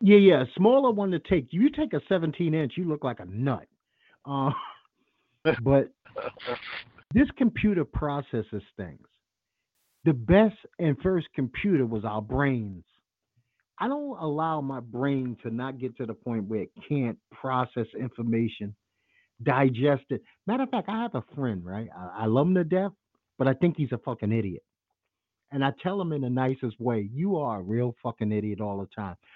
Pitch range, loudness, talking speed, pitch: 115-175 Hz, -27 LUFS, 175 wpm, 135 Hz